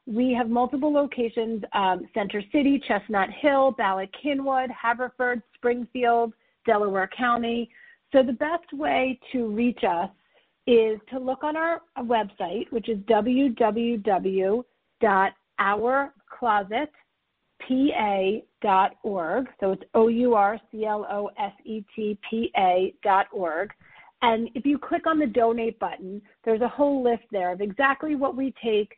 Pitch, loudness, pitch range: 235 Hz, -25 LUFS, 210-265 Hz